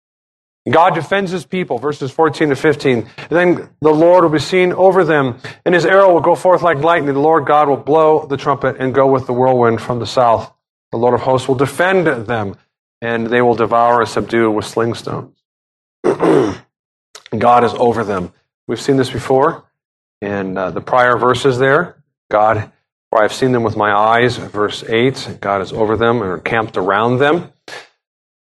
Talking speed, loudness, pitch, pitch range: 185 wpm, -14 LUFS, 130 Hz, 115-155 Hz